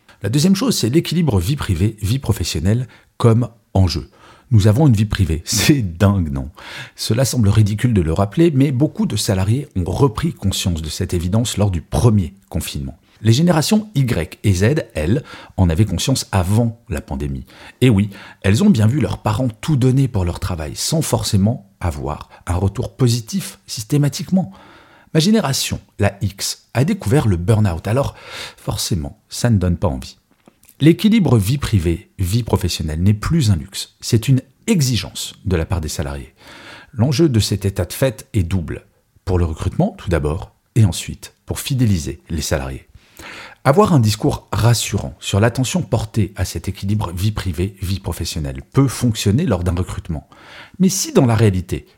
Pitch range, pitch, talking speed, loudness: 95-125 Hz, 105 Hz, 165 wpm, -18 LUFS